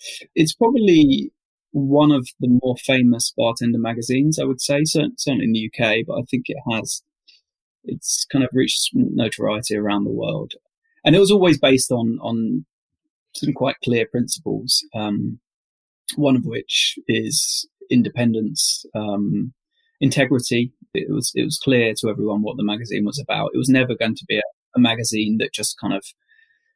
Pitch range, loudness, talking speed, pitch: 115-155 Hz, -19 LUFS, 165 wpm, 125 Hz